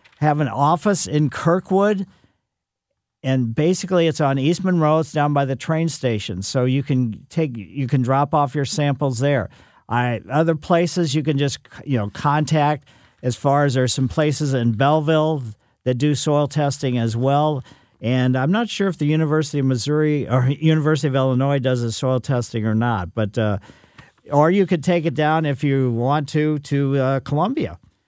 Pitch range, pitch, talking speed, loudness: 125-155 Hz, 140 Hz, 185 wpm, -20 LUFS